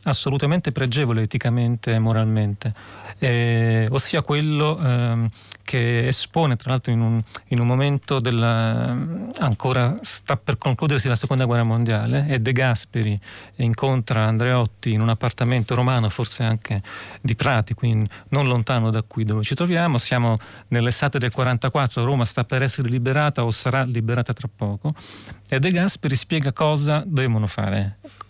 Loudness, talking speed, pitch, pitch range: -21 LUFS, 150 wpm, 125 Hz, 115-135 Hz